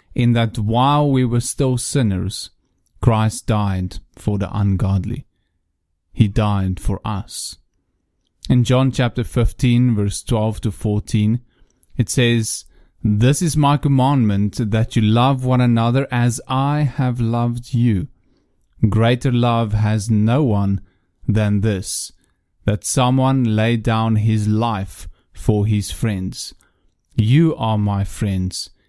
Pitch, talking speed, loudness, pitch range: 110 Hz, 125 wpm, -18 LUFS, 100-120 Hz